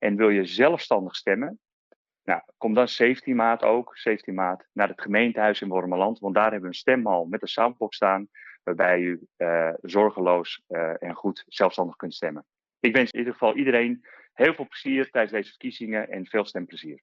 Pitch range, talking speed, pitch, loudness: 95-120 Hz, 185 wpm, 105 Hz, -24 LUFS